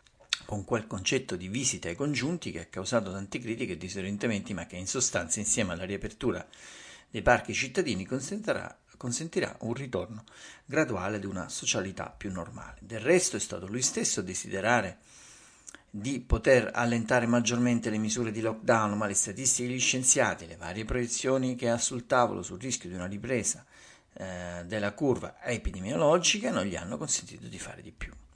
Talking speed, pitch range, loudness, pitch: 165 wpm, 100-125 Hz, -29 LUFS, 110 Hz